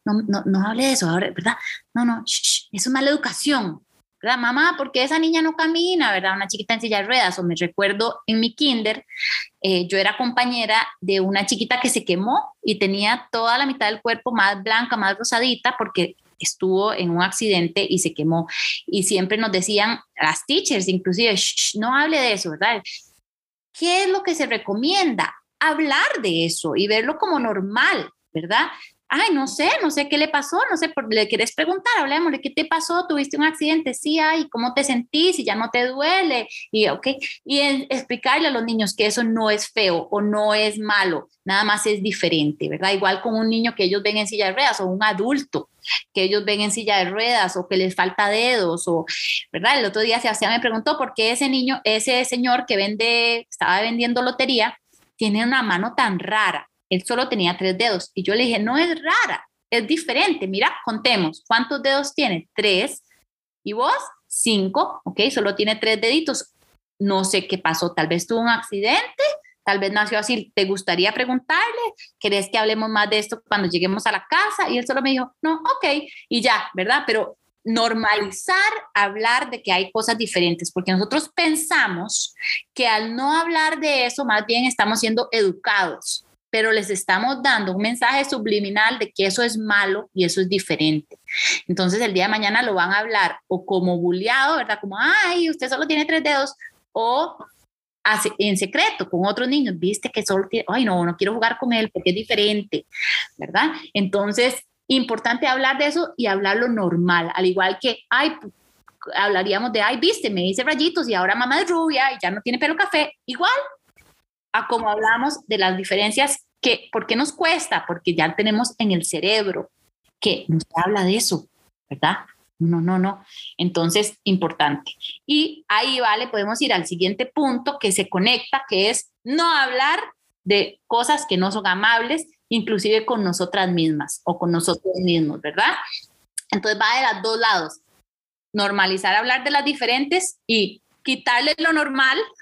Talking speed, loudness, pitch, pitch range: 190 wpm, -20 LUFS, 225 Hz, 195-270 Hz